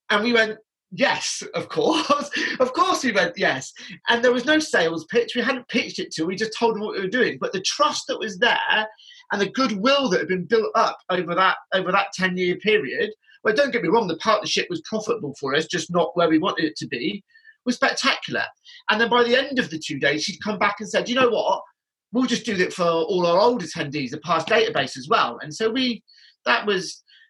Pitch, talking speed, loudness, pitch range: 220 Hz, 235 wpm, -22 LUFS, 180-255 Hz